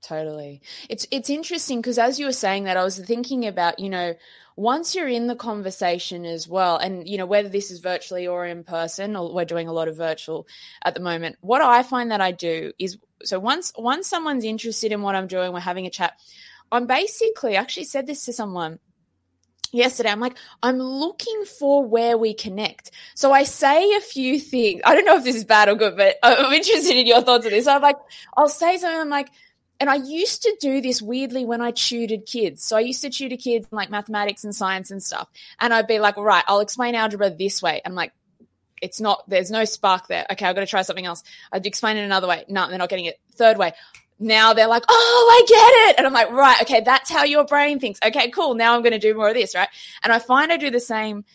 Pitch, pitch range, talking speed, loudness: 225 Hz, 190-265 Hz, 240 wpm, -19 LUFS